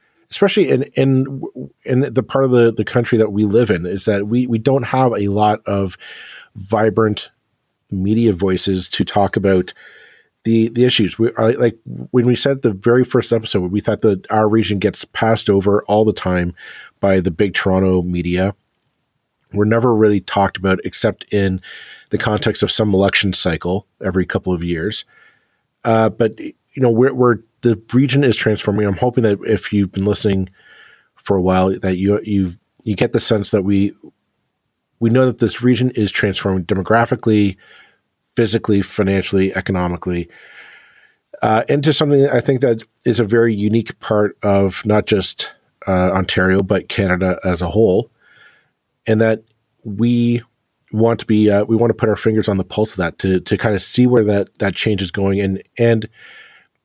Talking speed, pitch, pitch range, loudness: 175 wpm, 105 Hz, 95-115 Hz, -16 LUFS